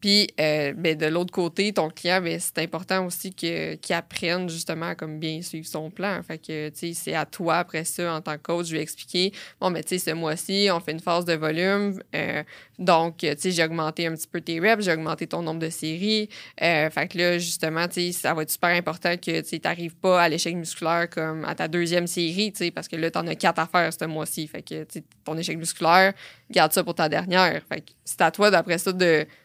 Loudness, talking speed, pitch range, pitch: -24 LUFS, 235 wpm, 160-180 Hz, 170 Hz